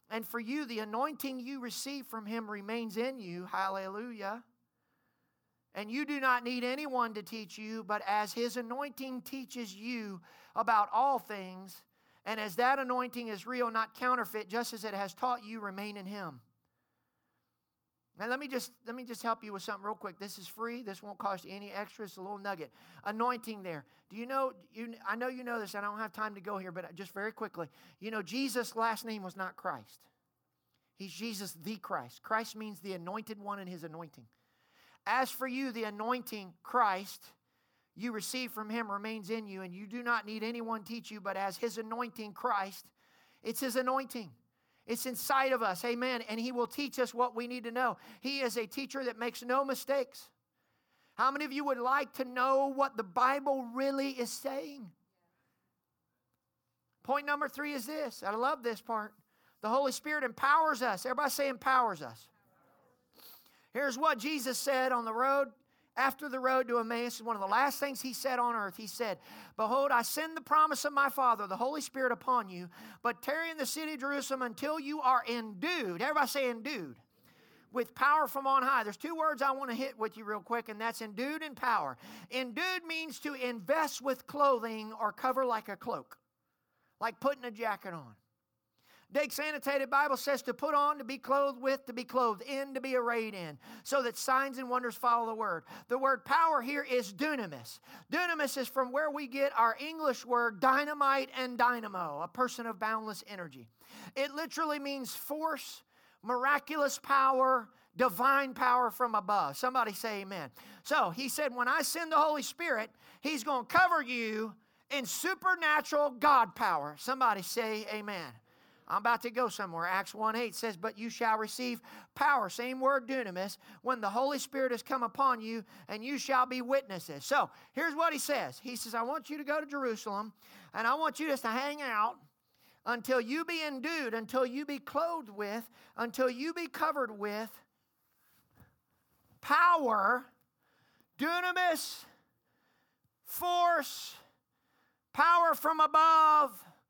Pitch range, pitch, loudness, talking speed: 215-275 Hz, 245 Hz, -33 LUFS, 180 wpm